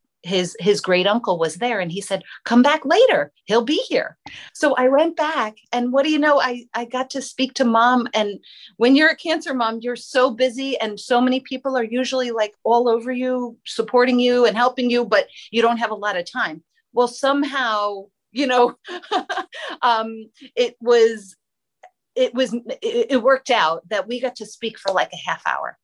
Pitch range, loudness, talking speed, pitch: 225-270 Hz, -20 LUFS, 200 wpm, 245 Hz